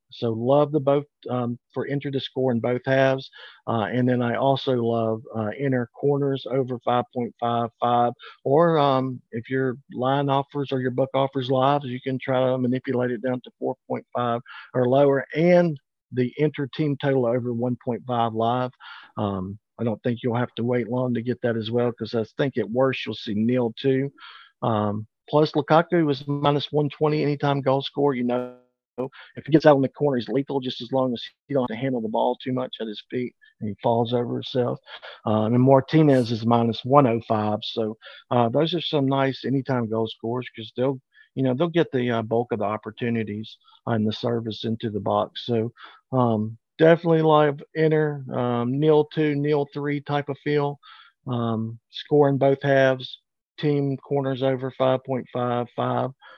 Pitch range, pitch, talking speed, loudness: 120-140 Hz, 125 Hz, 185 wpm, -24 LUFS